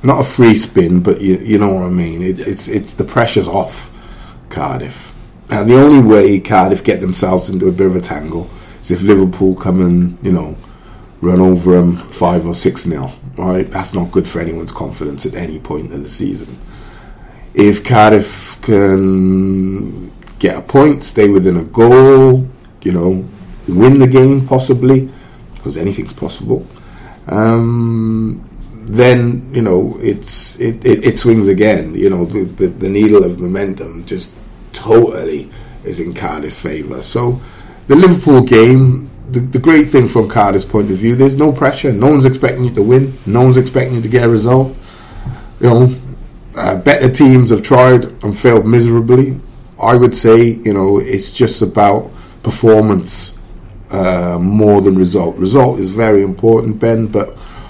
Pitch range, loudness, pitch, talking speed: 95-125 Hz, -11 LUFS, 110 Hz, 165 wpm